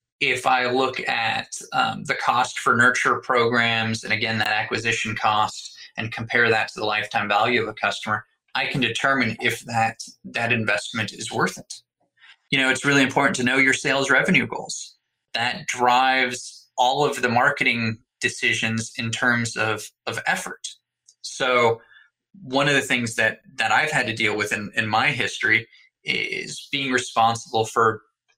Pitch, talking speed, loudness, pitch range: 120 Hz, 165 wpm, -21 LUFS, 115-130 Hz